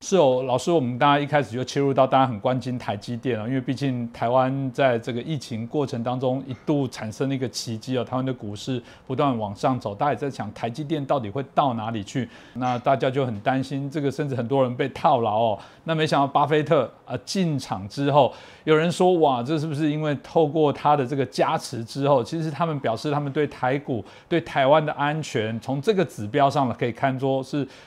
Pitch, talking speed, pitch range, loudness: 135 Hz, 330 characters per minute, 125-150 Hz, -24 LUFS